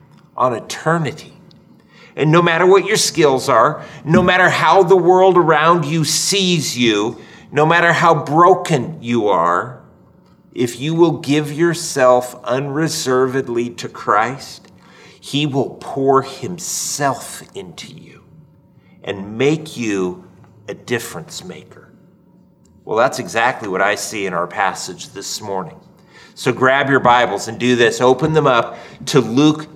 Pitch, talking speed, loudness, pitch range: 150 Hz, 135 wpm, -15 LUFS, 125-170 Hz